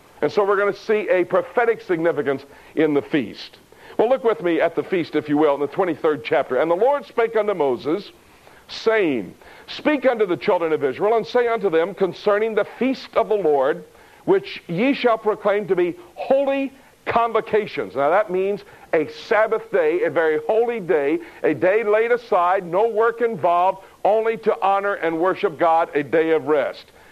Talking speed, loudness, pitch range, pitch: 185 wpm, -20 LUFS, 175-235 Hz, 205 Hz